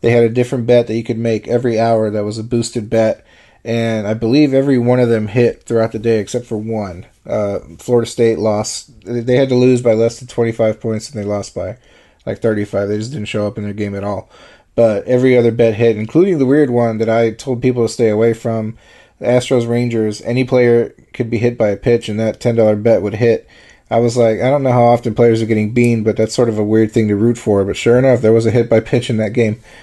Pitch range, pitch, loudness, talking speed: 110-120 Hz, 115 Hz, -15 LUFS, 255 wpm